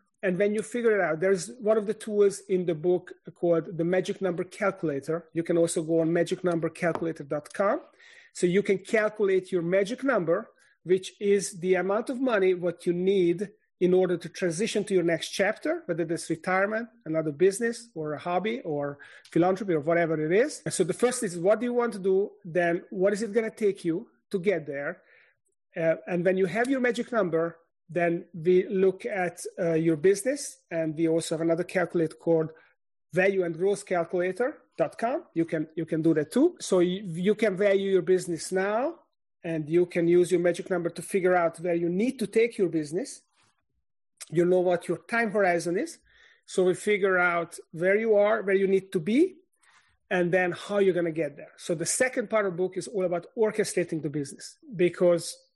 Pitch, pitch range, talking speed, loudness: 185 Hz, 170-210 Hz, 195 wpm, -27 LUFS